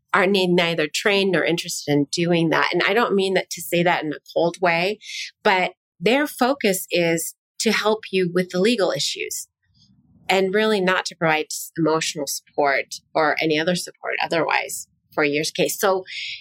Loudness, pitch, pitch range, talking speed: -21 LUFS, 180 Hz, 165-200 Hz, 170 wpm